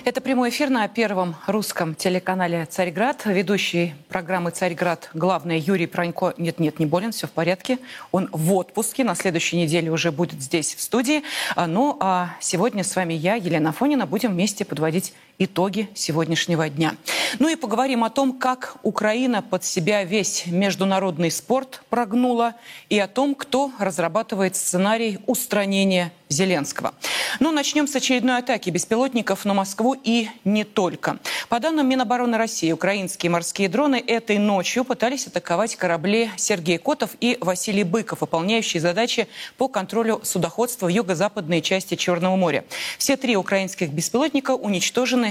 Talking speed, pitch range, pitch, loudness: 145 wpm, 180-235 Hz, 200 Hz, -22 LUFS